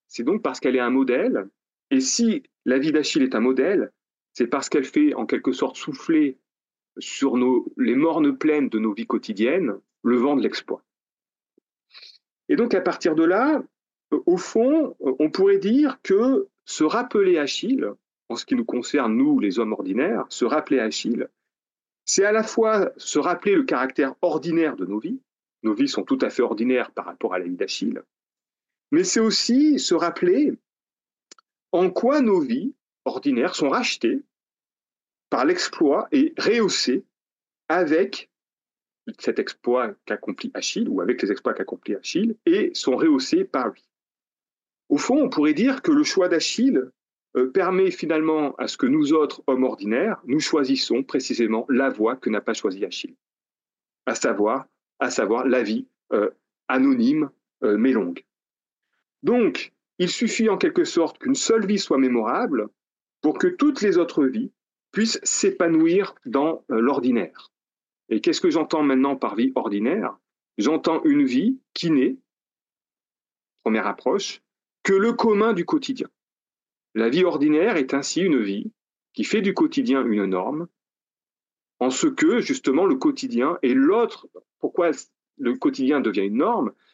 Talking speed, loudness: 155 wpm, -22 LUFS